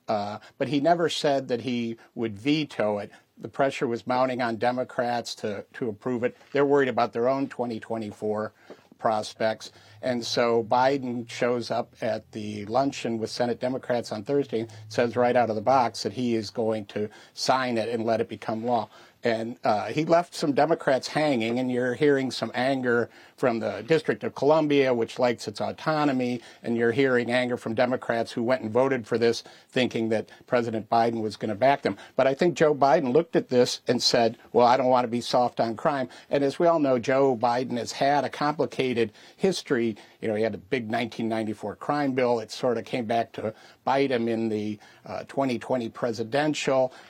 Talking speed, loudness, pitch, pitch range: 195 wpm, -26 LUFS, 120 Hz, 115-135 Hz